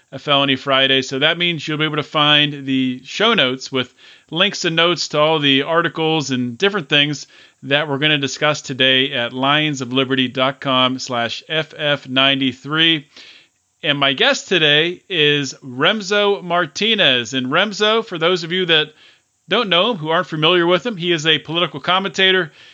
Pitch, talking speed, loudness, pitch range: 150 Hz, 160 wpm, -16 LUFS, 135-170 Hz